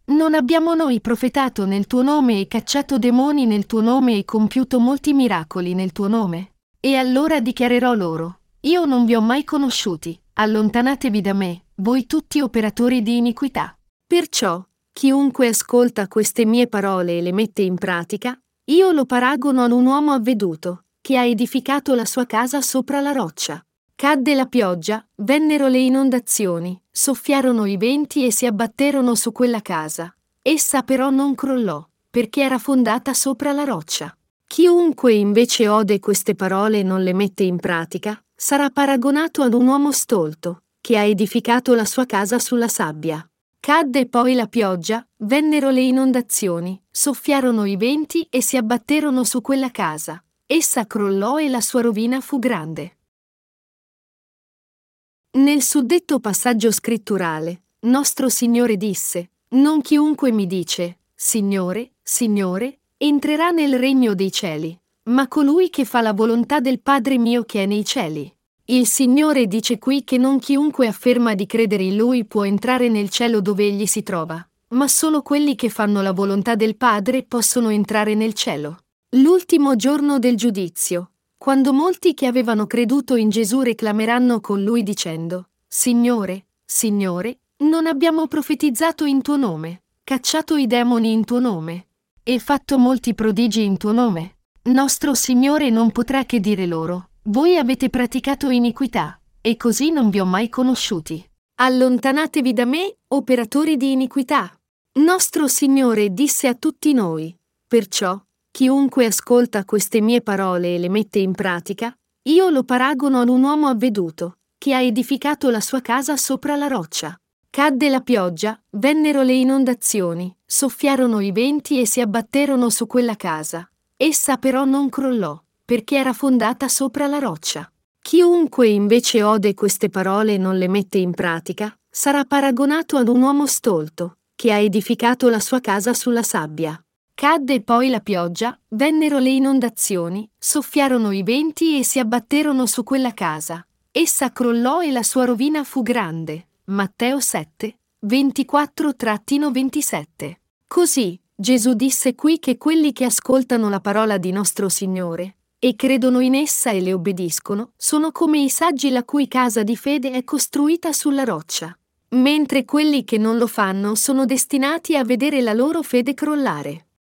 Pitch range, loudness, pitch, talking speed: 210-275 Hz, -18 LUFS, 245 Hz, 150 wpm